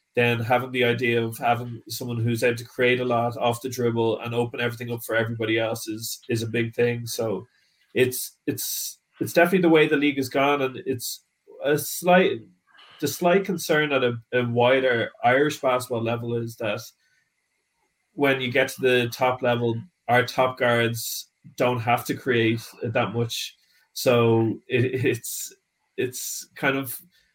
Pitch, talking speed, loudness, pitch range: 125 Hz, 170 wpm, -24 LUFS, 115-135 Hz